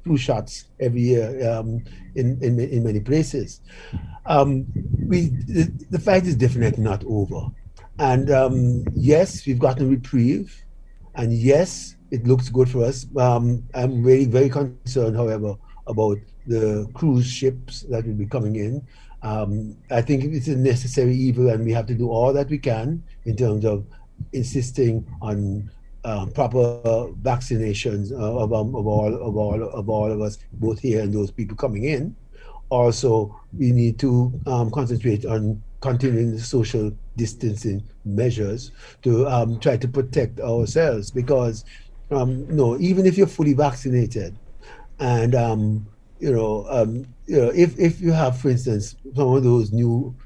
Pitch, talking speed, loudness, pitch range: 120 Hz, 160 wpm, -21 LUFS, 110-130 Hz